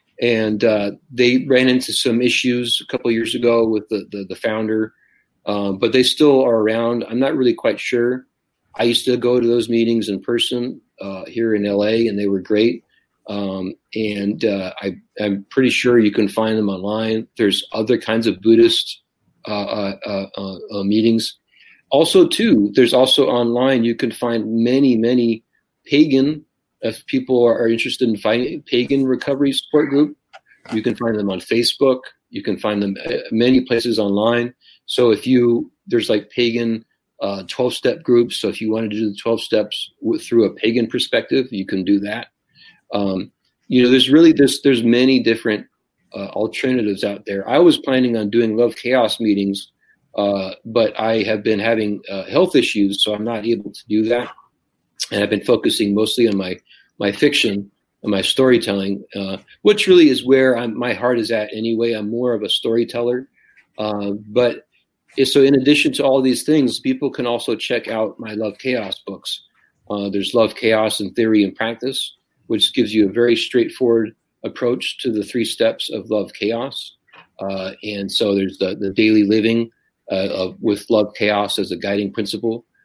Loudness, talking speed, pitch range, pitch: -18 LUFS, 185 wpm, 105-125 Hz, 115 Hz